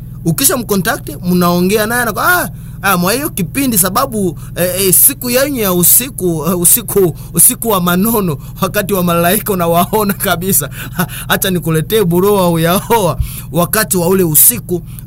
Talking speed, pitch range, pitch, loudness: 135 wpm, 165-205 Hz, 180 Hz, -11 LUFS